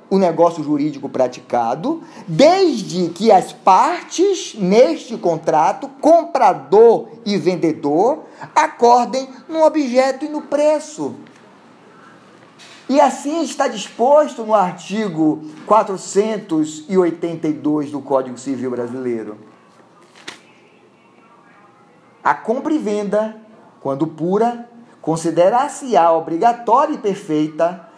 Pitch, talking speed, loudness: 210 Hz, 85 wpm, -17 LUFS